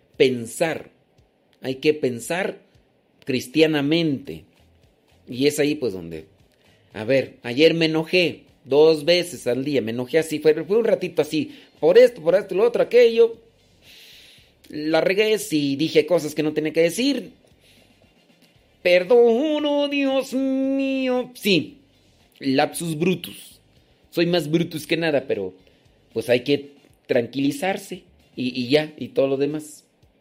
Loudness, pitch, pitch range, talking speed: -21 LUFS, 155 Hz, 130-205 Hz, 135 wpm